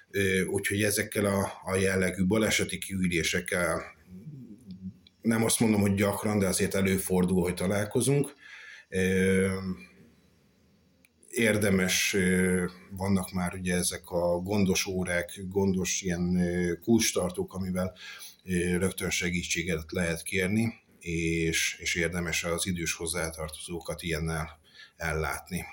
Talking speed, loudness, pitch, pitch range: 100 wpm, -28 LUFS, 95 Hz, 90-100 Hz